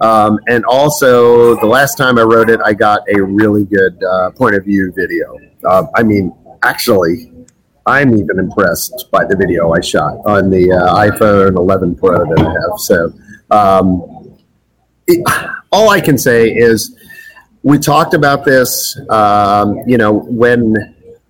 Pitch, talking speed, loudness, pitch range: 110 Hz, 160 wpm, -10 LUFS, 100-130 Hz